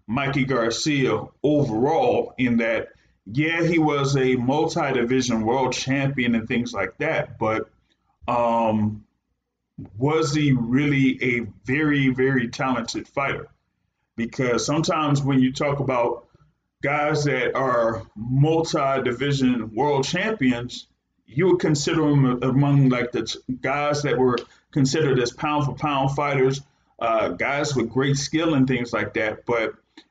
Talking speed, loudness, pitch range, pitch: 125 wpm, -22 LUFS, 120-145 Hz, 135 Hz